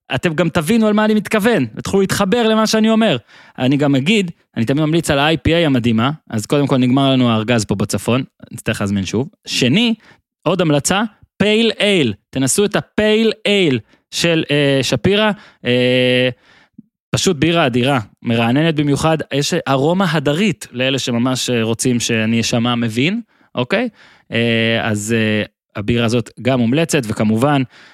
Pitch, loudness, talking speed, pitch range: 140 Hz, -16 LUFS, 145 wpm, 120-195 Hz